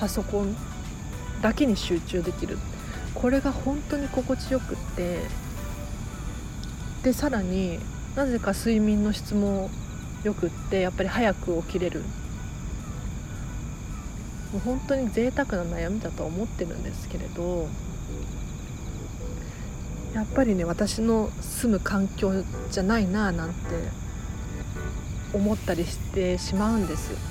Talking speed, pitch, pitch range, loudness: 225 characters per minute, 200 Hz, 170-225 Hz, -28 LUFS